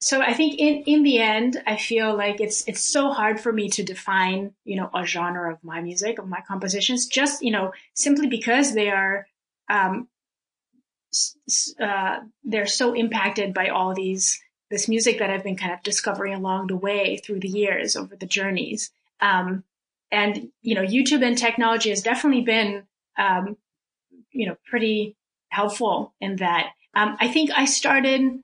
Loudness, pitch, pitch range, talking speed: -22 LUFS, 210 Hz, 195-245 Hz, 175 wpm